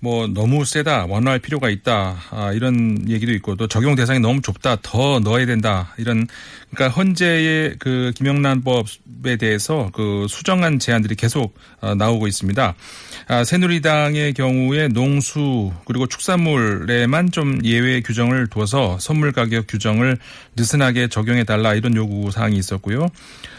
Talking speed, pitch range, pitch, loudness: 320 characters per minute, 110-135 Hz, 120 Hz, -18 LUFS